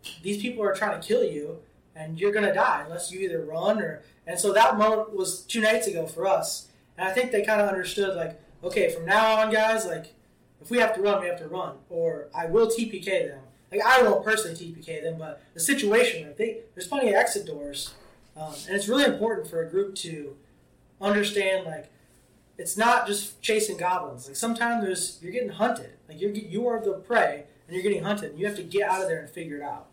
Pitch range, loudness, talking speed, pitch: 165-220 Hz, -26 LUFS, 230 wpm, 195 Hz